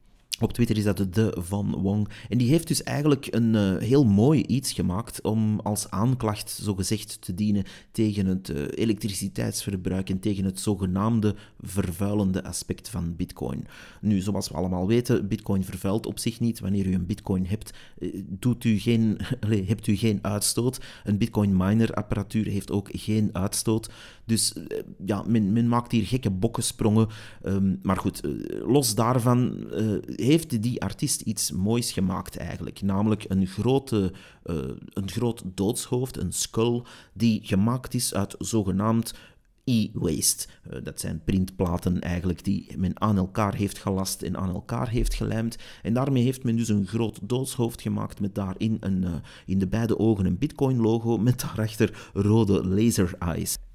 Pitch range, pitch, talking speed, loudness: 95-115 Hz, 105 Hz, 160 wpm, -26 LUFS